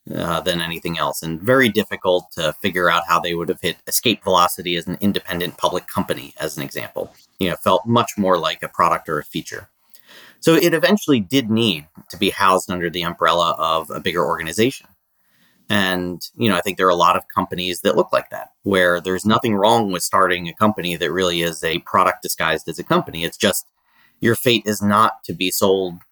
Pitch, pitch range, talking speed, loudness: 95 Hz, 85-110 Hz, 210 wpm, -19 LUFS